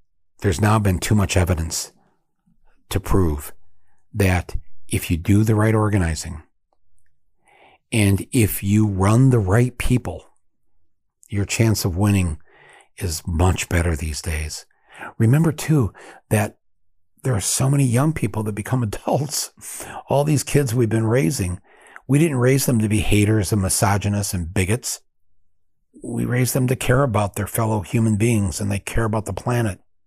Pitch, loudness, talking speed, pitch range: 100 Hz, -20 LUFS, 150 wpm, 90-115 Hz